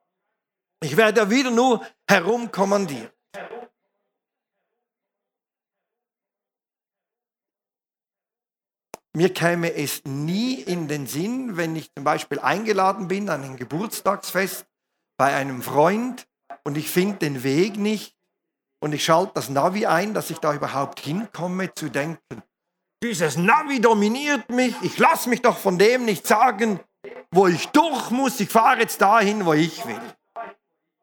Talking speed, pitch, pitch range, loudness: 130 wpm, 190 Hz, 155-220 Hz, -21 LUFS